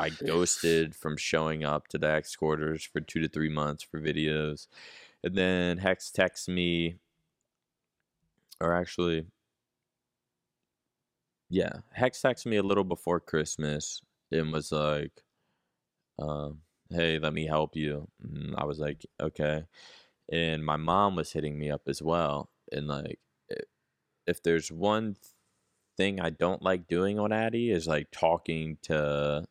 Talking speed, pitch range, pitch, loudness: 140 wpm, 75-90 Hz, 80 Hz, -30 LUFS